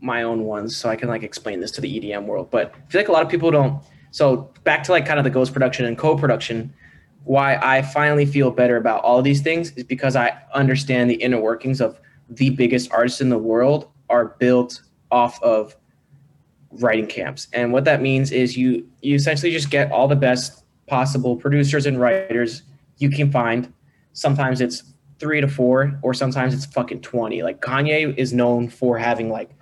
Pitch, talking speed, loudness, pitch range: 130 Hz, 200 wpm, -19 LUFS, 120-140 Hz